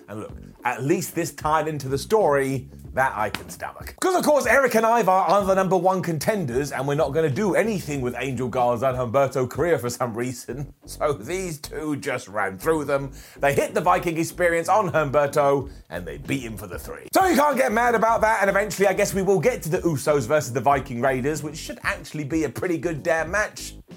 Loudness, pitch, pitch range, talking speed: -22 LUFS, 160 Hz, 140-195 Hz, 230 wpm